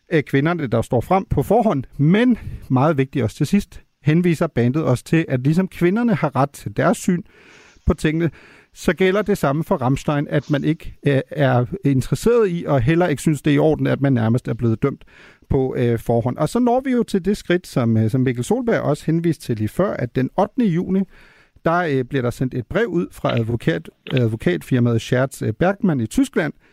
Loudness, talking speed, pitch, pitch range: -19 LUFS, 200 wpm, 150 Hz, 130-185 Hz